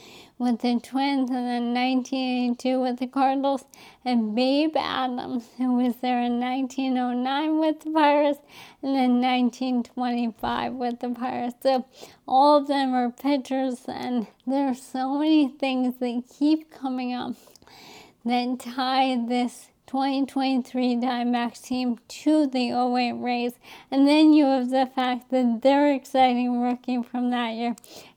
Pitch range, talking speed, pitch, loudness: 245-270 Hz, 135 wpm, 255 Hz, -24 LUFS